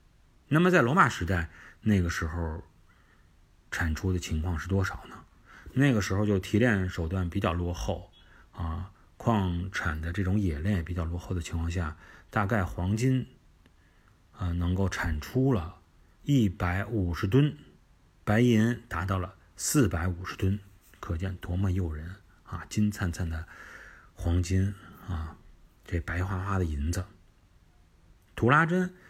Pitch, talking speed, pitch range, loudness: 90 Hz, 205 characters per minute, 85-100 Hz, -29 LUFS